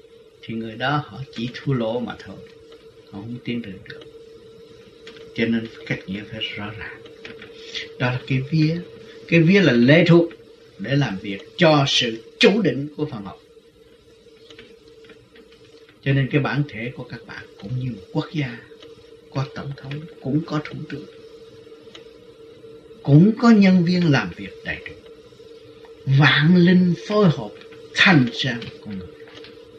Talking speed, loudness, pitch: 155 wpm, -20 LUFS, 170 Hz